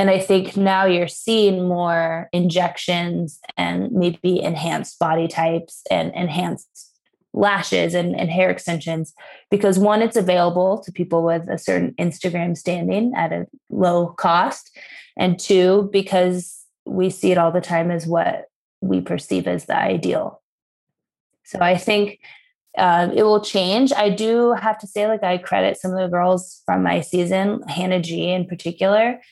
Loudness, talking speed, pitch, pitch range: -19 LUFS, 160 wpm, 180 Hz, 170-195 Hz